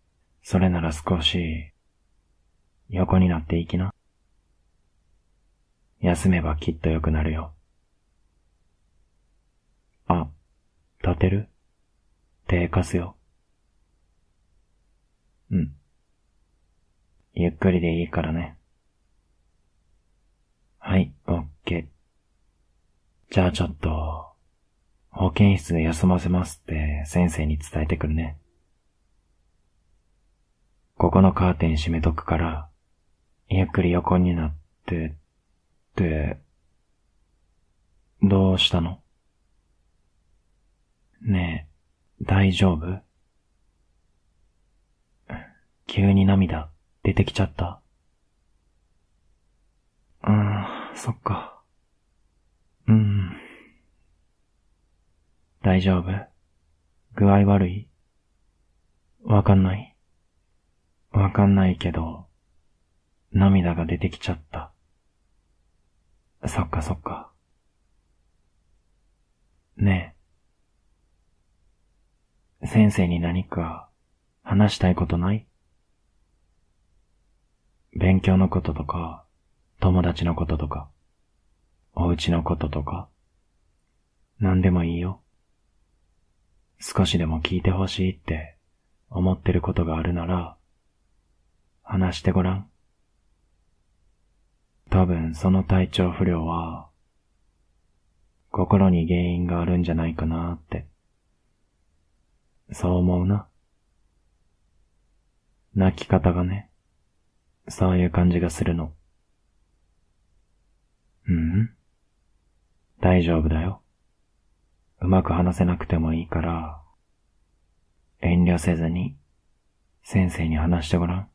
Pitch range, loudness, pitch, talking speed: 75-90 Hz, -23 LUFS, 80 Hz, 155 characters per minute